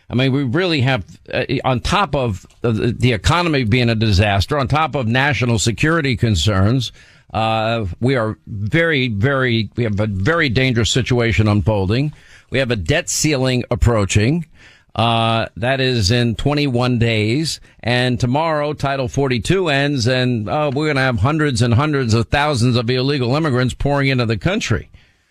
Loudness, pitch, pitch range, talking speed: -17 LUFS, 125 Hz, 115-140 Hz, 160 wpm